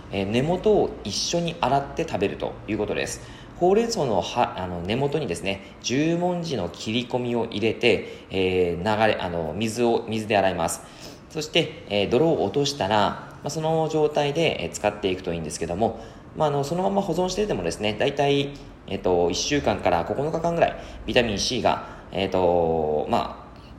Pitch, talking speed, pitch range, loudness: 120 Hz, 345 characters per minute, 95-155 Hz, -24 LUFS